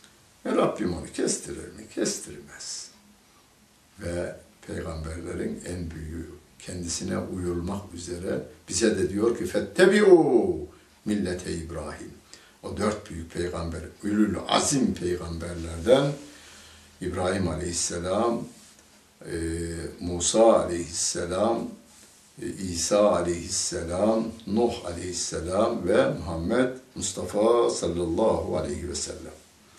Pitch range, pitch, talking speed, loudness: 85-105 Hz, 90 Hz, 85 wpm, -26 LUFS